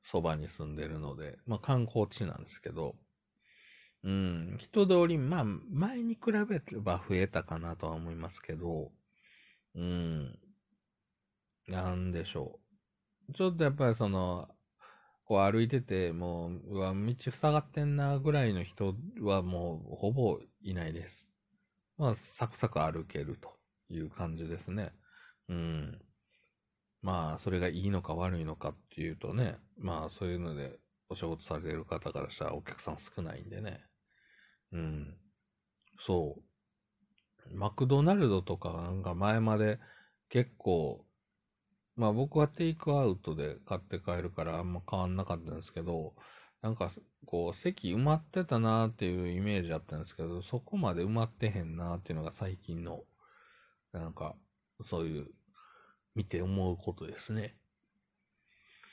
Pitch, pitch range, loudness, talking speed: 95 Hz, 85-115 Hz, -35 LUFS, 285 characters per minute